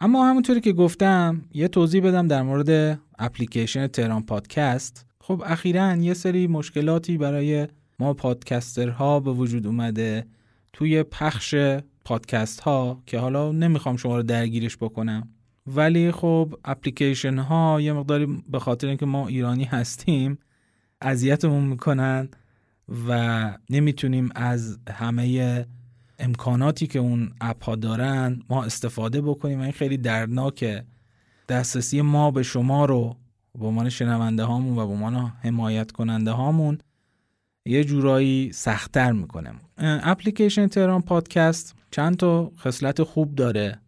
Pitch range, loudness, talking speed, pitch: 120-150 Hz, -23 LUFS, 125 wpm, 130 Hz